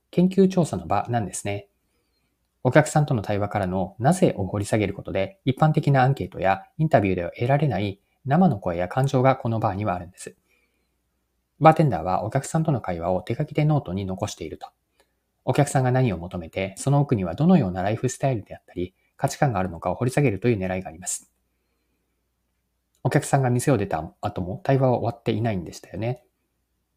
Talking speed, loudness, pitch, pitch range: 415 characters per minute, -23 LUFS, 105 Hz, 90-135 Hz